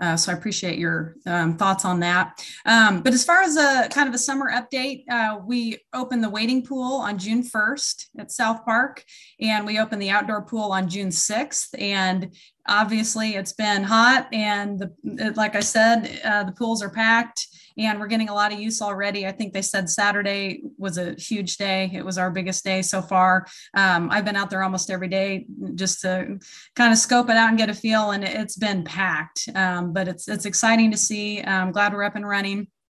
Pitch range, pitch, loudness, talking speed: 190-225 Hz, 205 Hz, -22 LUFS, 210 wpm